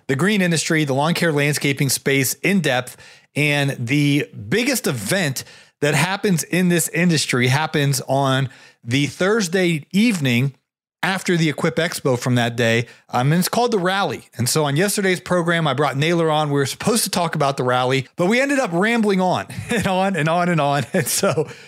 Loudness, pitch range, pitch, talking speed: -19 LUFS, 140-185 Hz, 155 Hz, 190 wpm